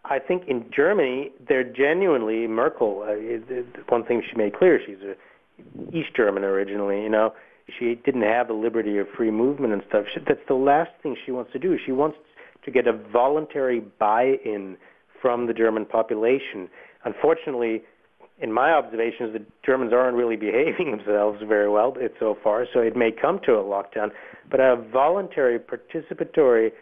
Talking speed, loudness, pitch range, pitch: 175 wpm, -23 LUFS, 105-130 Hz, 115 Hz